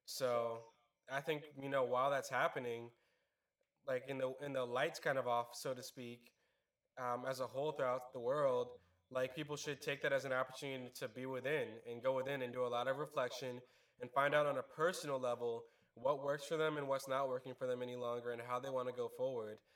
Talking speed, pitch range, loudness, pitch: 220 wpm, 125-145 Hz, -41 LUFS, 130 Hz